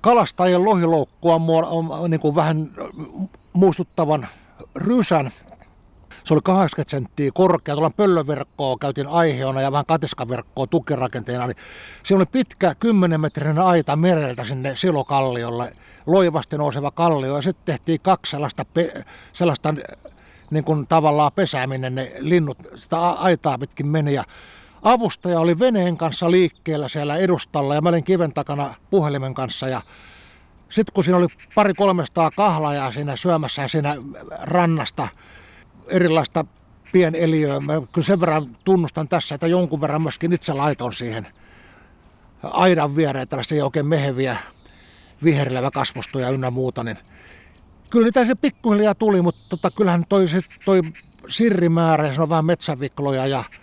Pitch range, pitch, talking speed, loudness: 135-175 Hz, 155 Hz, 125 wpm, -20 LUFS